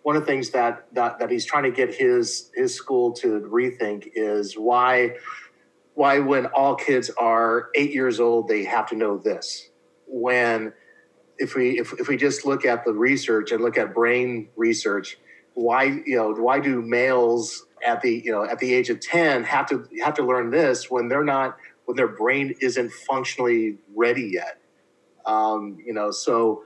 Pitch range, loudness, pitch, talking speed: 115-155 Hz, -22 LUFS, 125 Hz, 185 wpm